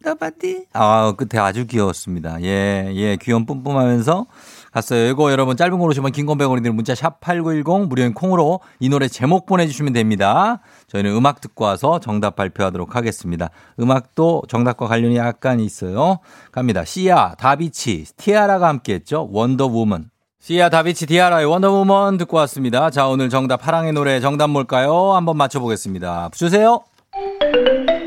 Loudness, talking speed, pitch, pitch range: -17 LUFS, 360 characters per minute, 135 Hz, 115-170 Hz